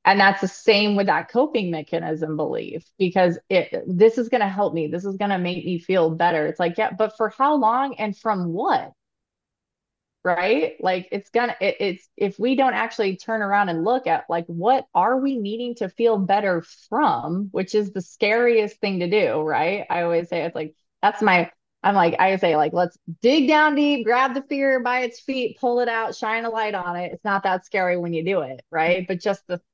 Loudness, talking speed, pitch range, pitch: -22 LUFS, 220 wpm, 175-230 Hz, 200 Hz